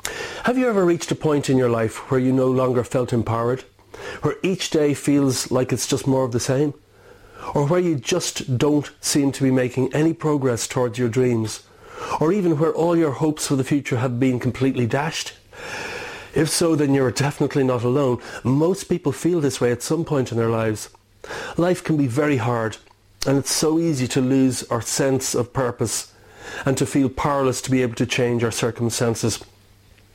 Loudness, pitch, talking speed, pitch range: -21 LUFS, 135 Hz, 195 wpm, 125-150 Hz